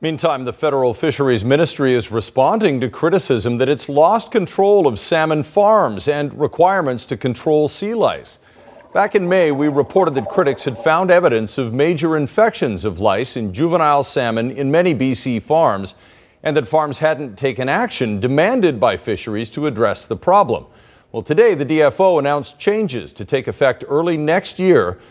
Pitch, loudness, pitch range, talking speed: 150 Hz, -16 LUFS, 130-175 Hz, 165 wpm